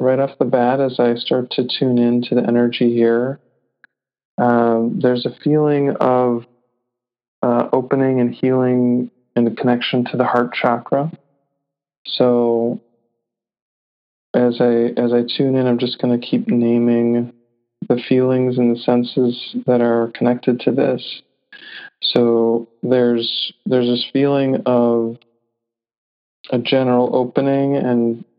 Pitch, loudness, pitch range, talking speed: 120 Hz, -17 LUFS, 120-125 Hz, 130 wpm